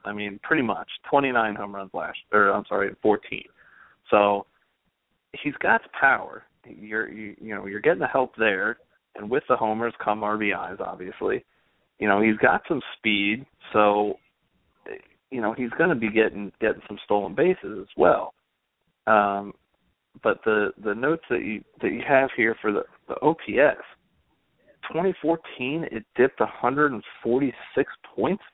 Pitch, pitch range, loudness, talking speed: 110 Hz, 105-125 Hz, -24 LUFS, 150 wpm